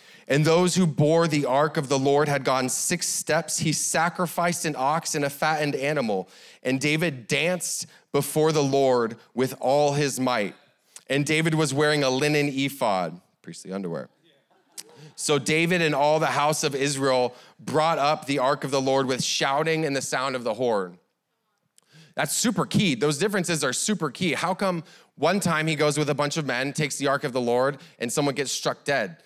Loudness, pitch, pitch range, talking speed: -24 LUFS, 150 Hz, 140-165 Hz, 190 wpm